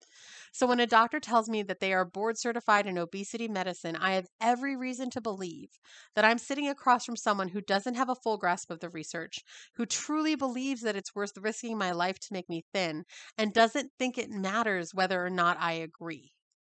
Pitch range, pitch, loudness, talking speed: 185-240 Hz, 210 Hz, -30 LUFS, 210 wpm